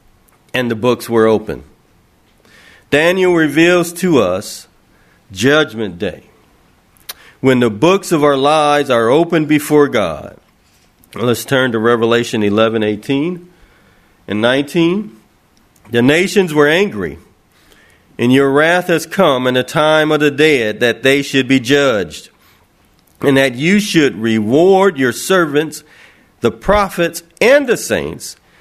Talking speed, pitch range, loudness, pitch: 130 wpm, 120-165 Hz, -13 LUFS, 140 Hz